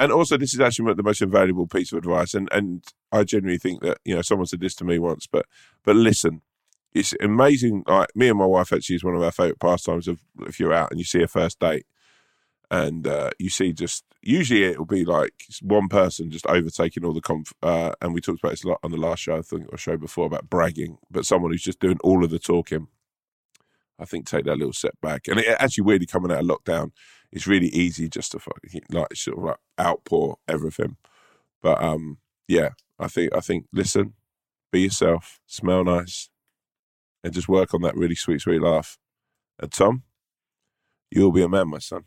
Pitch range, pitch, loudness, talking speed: 85-100 Hz, 90 Hz, -22 LUFS, 220 wpm